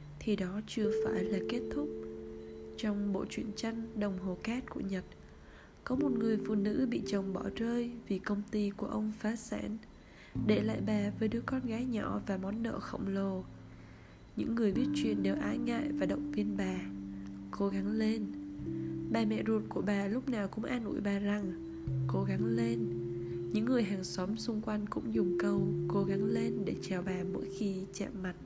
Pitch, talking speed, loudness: 185 Hz, 195 wpm, -35 LUFS